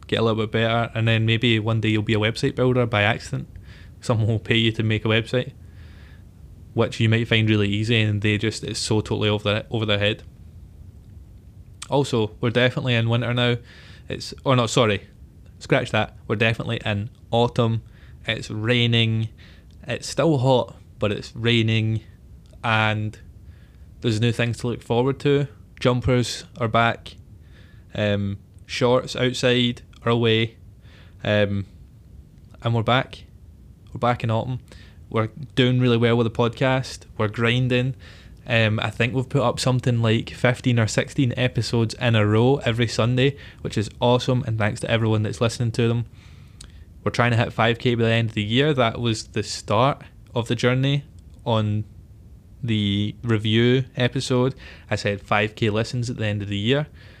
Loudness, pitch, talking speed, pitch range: -22 LUFS, 115 Hz, 165 wpm, 105-120 Hz